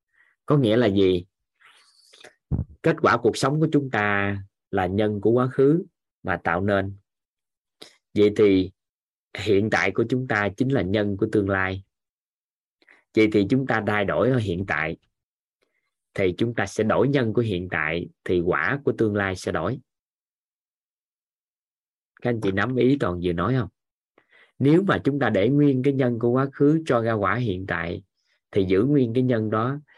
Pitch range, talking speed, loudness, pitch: 95-130 Hz, 175 wpm, -23 LUFS, 110 Hz